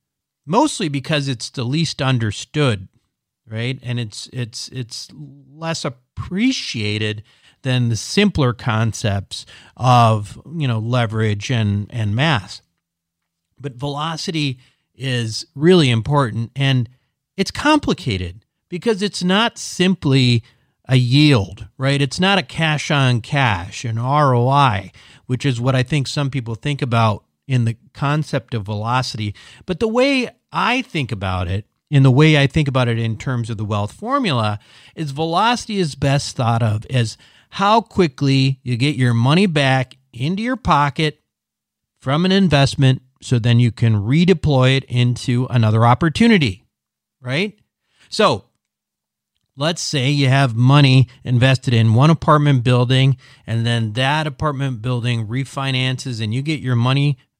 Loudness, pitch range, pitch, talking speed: -18 LUFS, 115-150 Hz, 130 Hz, 140 wpm